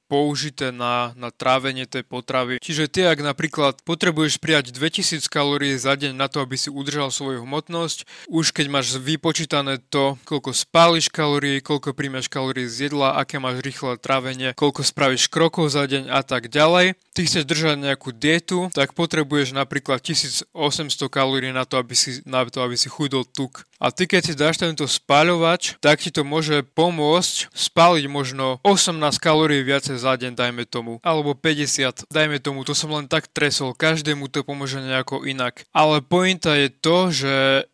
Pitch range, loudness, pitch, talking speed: 135-155 Hz, -20 LUFS, 145 Hz, 170 wpm